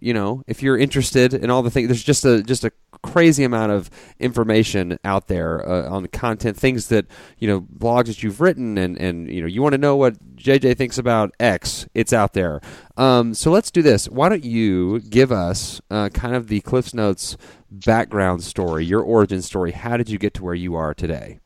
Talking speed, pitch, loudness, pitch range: 220 wpm, 110 Hz, -19 LUFS, 95-125 Hz